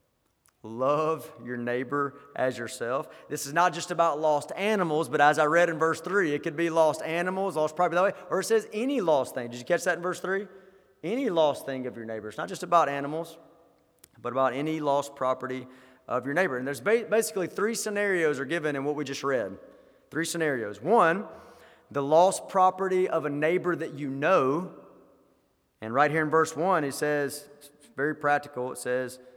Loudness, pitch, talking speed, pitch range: -27 LUFS, 155 Hz, 200 wpm, 140-175 Hz